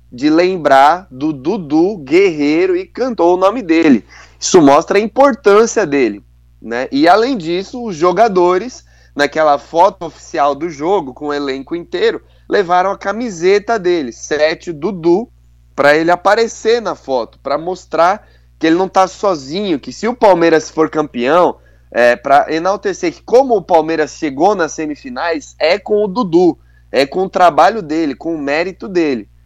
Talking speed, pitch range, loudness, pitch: 155 wpm, 150-225 Hz, -13 LUFS, 180 Hz